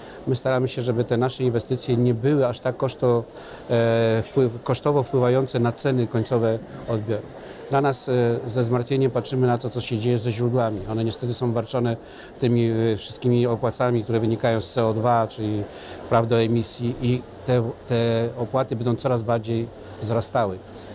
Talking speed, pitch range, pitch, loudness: 145 wpm, 115-125 Hz, 120 Hz, -23 LUFS